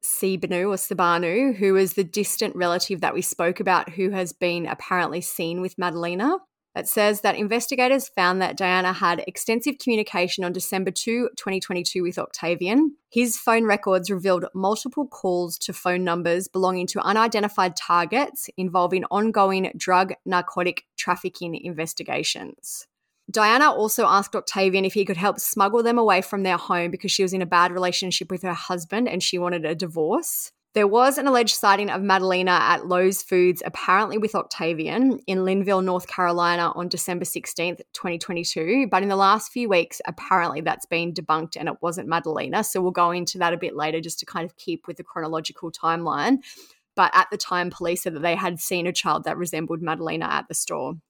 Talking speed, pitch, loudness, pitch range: 180 wpm, 185 Hz, -23 LUFS, 175-205 Hz